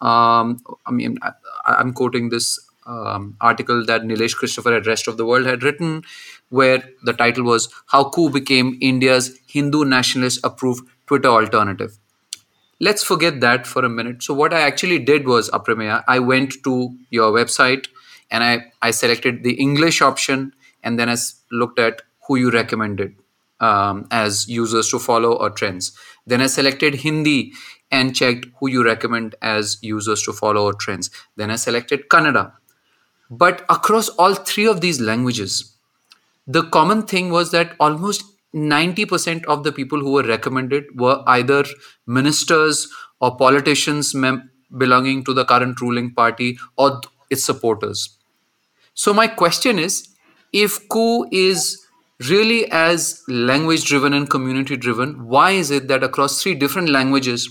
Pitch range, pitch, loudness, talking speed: 120-155 Hz, 130 Hz, -17 LUFS, 155 wpm